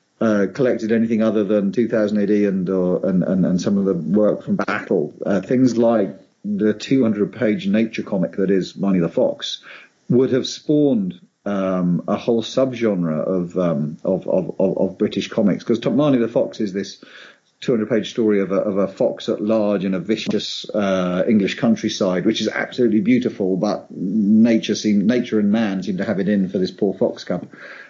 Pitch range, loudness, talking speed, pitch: 95-115 Hz, -19 LUFS, 185 wpm, 105 Hz